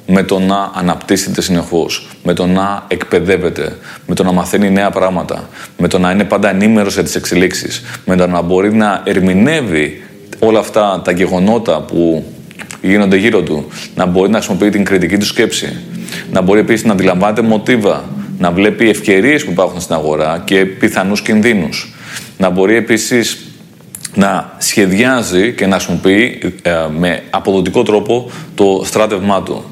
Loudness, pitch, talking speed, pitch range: -12 LUFS, 95 Hz, 155 wpm, 90-105 Hz